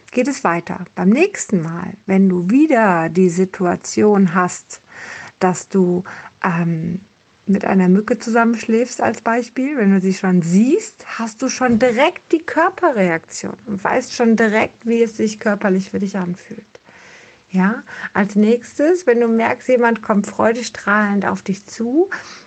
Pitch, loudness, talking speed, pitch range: 215 Hz, -16 LUFS, 145 wpm, 190-245 Hz